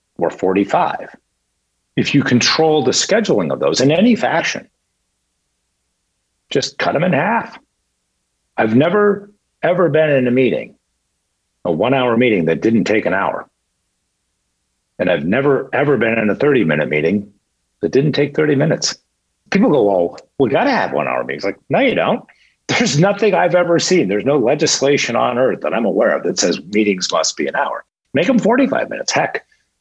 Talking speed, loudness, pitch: 180 wpm, -16 LUFS, 125 Hz